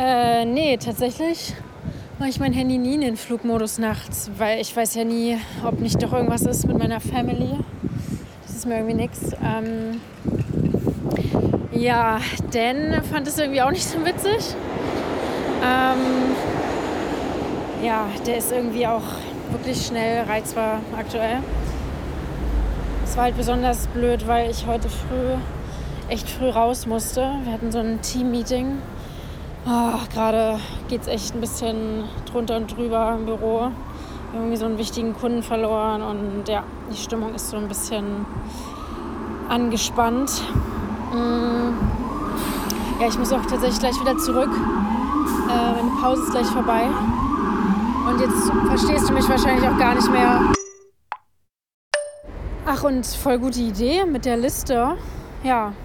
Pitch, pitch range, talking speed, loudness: 235 Hz, 225-255 Hz, 135 wpm, -22 LUFS